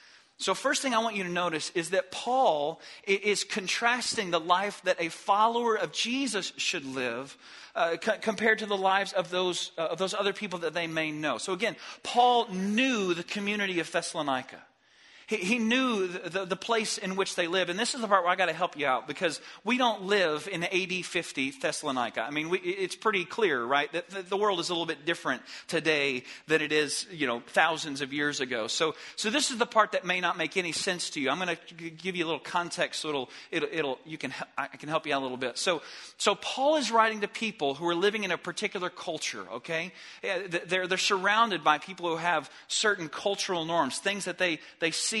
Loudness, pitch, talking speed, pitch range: -29 LUFS, 185 Hz, 220 wpm, 160-205 Hz